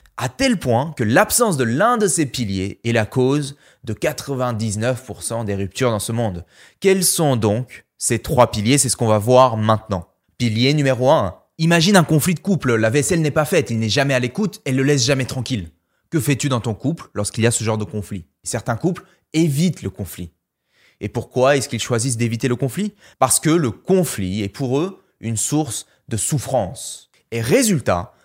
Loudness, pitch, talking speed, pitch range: -19 LUFS, 125 Hz, 200 wpm, 110-145 Hz